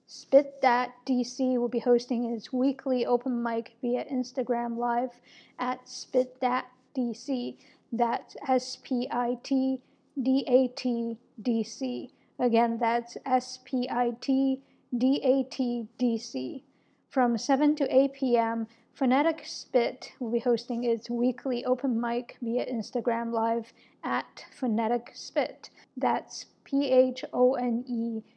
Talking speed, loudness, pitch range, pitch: 135 wpm, -29 LUFS, 235-260 Hz, 250 Hz